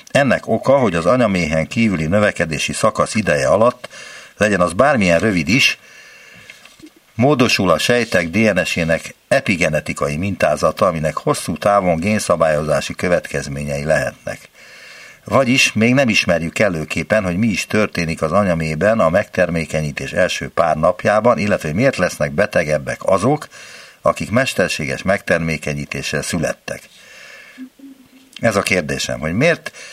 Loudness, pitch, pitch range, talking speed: -16 LUFS, 90 Hz, 80-110 Hz, 115 wpm